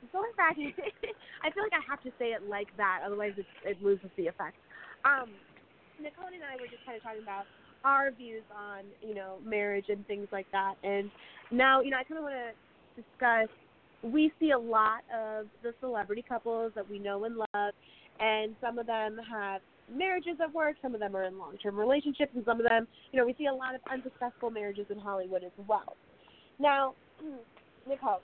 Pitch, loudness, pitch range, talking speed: 230 Hz, -32 LUFS, 205-270 Hz, 205 wpm